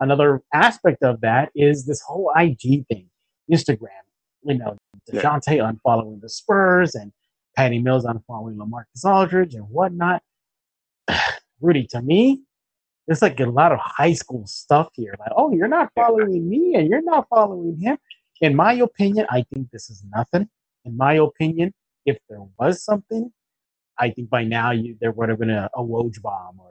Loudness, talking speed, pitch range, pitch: -20 LUFS, 170 wpm, 115-185 Hz, 140 Hz